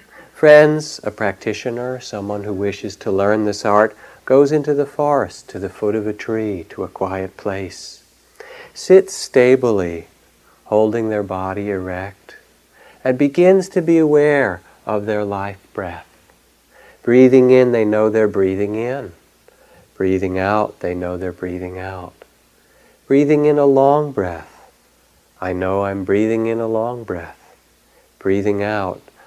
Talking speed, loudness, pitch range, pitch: 140 wpm, -17 LUFS, 95-135 Hz, 105 Hz